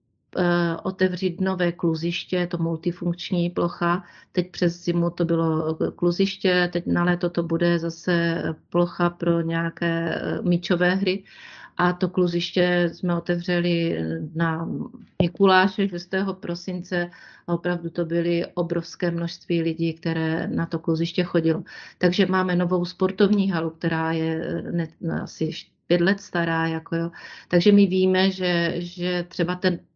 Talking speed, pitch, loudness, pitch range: 130 wpm, 175 Hz, -24 LUFS, 170-180 Hz